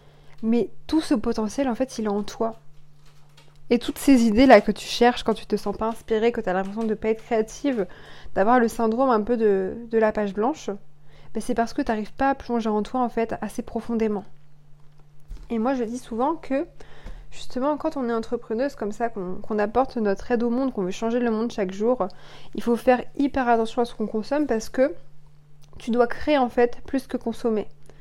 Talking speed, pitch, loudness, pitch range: 225 wpm, 230 Hz, -24 LUFS, 205-245 Hz